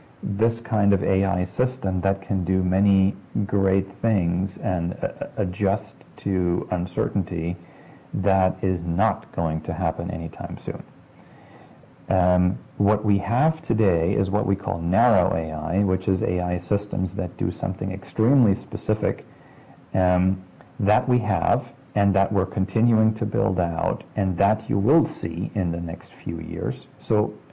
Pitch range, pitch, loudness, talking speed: 90-105 Hz, 95 Hz, -23 LUFS, 145 wpm